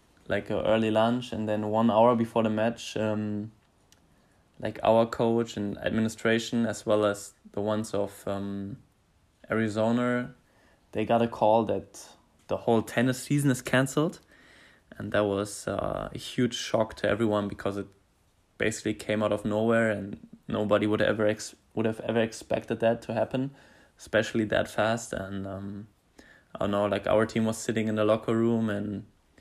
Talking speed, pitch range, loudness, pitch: 165 wpm, 105-115 Hz, -28 LUFS, 110 Hz